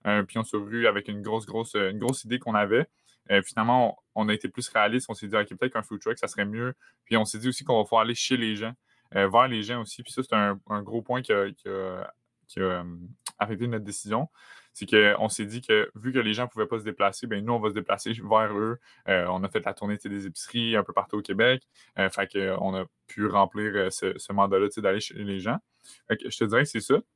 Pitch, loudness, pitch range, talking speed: 110 Hz, -27 LUFS, 100-115 Hz, 265 wpm